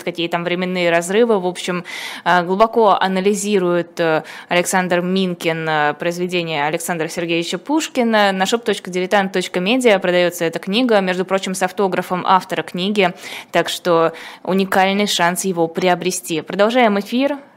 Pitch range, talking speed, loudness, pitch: 175-200 Hz, 115 wpm, -17 LUFS, 185 Hz